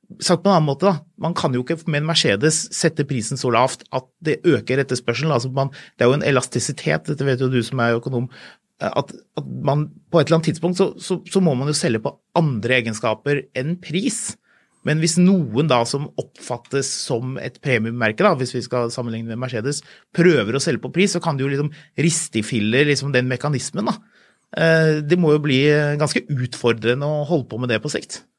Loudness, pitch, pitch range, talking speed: -20 LUFS, 145 Hz, 125-165 Hz, 190 wpm